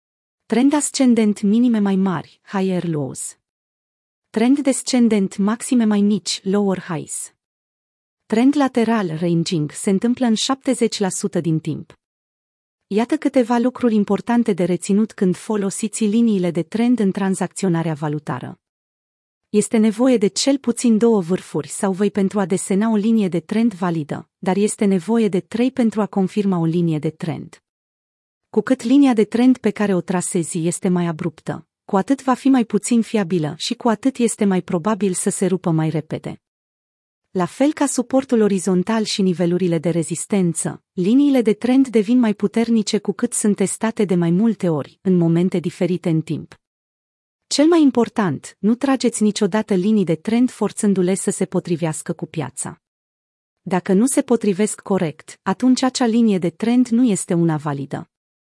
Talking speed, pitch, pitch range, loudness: 155 wpm, 205 Hz, 180-230 Hz, -19 LUFS